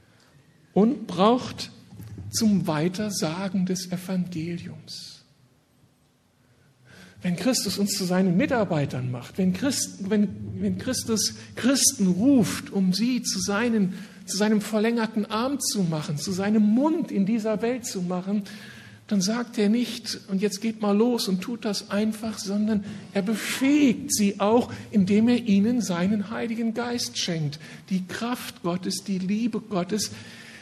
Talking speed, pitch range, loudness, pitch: 135 wpm, 185-225 Hz, -25 LUFS, 205 Hz